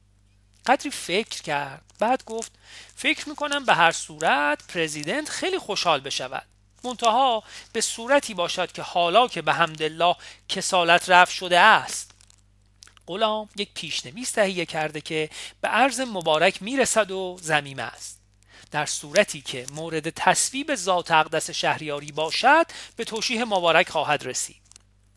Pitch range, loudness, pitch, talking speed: 150-220 Hz, -23 LUFS, 170 Hz, 130 wpm